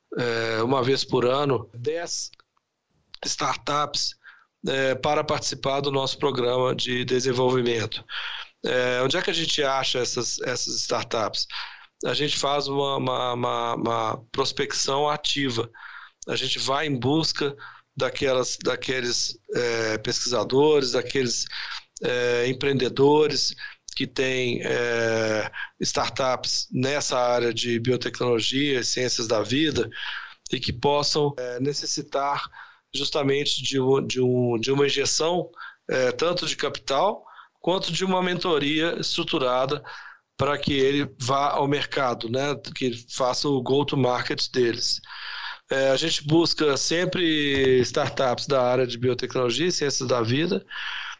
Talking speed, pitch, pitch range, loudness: 125 wpm, 135 Hz, 125-145 Hz, -24 LUFS